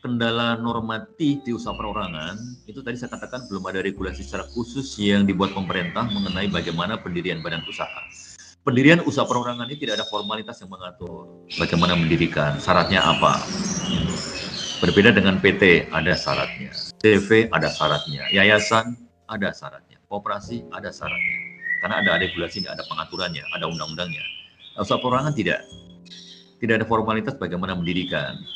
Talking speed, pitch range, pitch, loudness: 135 wpm, 90-120 Hz, 110 Hz, -22 LUFS